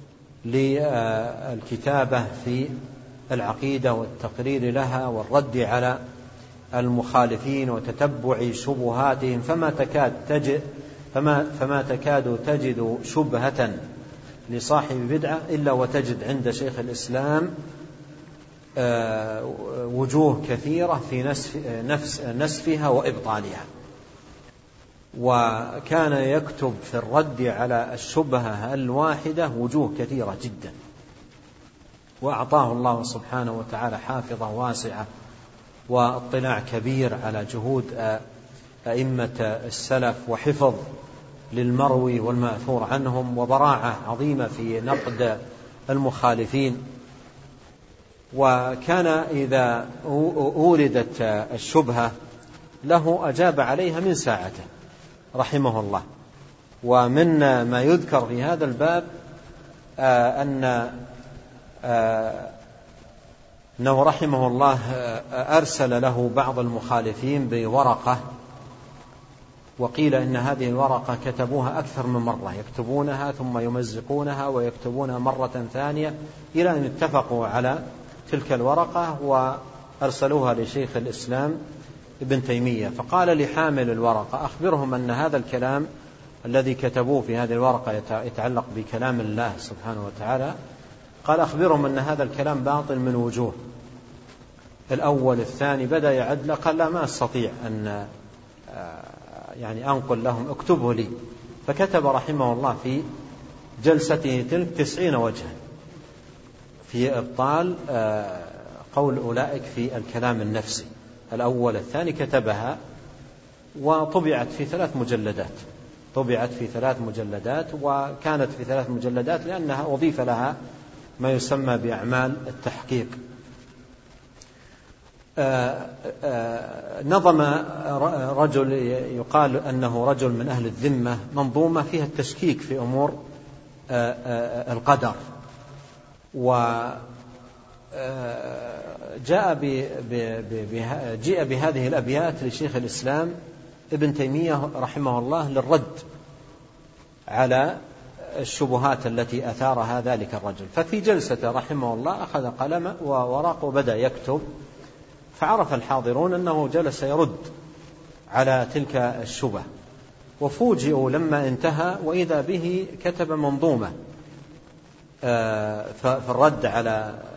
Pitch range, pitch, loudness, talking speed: 120-145 Hz, 130 Hz, -24 LUFS, 90 wpm